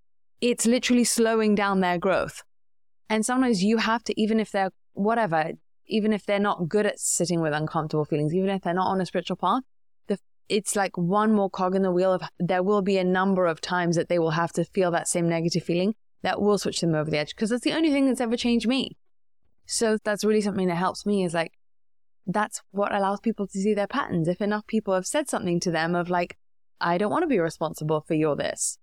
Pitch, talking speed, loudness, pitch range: 195 Hz, 235 wpm, -25 LUFS, 175-215 Hz